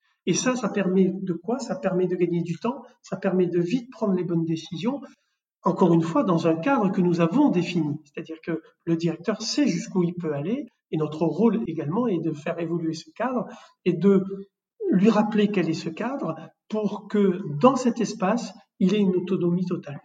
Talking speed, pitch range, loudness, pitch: 200 wpm, 170-215 Hz, -24 LUFS, 185 Hz